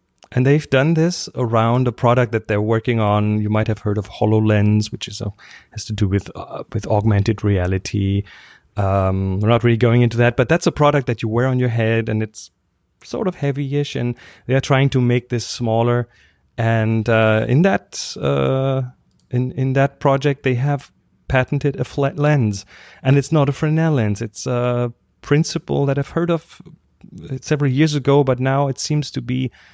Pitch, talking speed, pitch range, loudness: 120 Hz, 190 wpm, 110-140 Hz, -18 LUFS